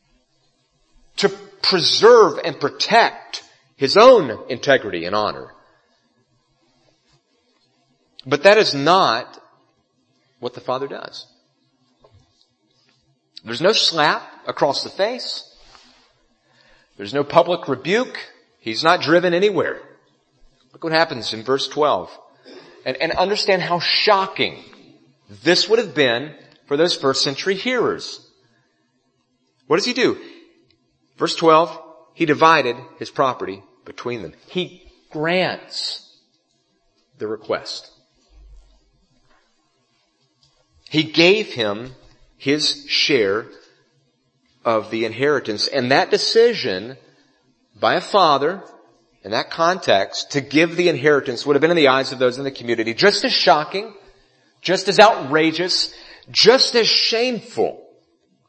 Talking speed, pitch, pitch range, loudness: 110 wpm, 165 Hz, 140-210 Hz, -17 LUFS